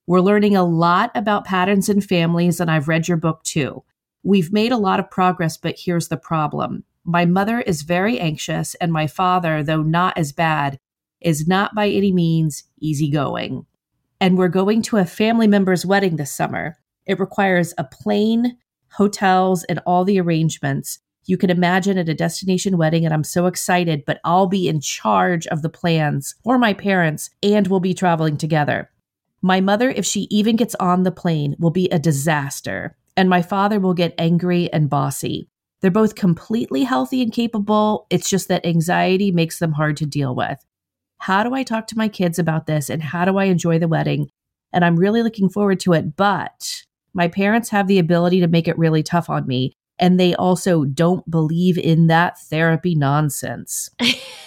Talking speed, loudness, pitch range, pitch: 185 wpm, -18 LUFS, 160-195 Hz, 175 Hz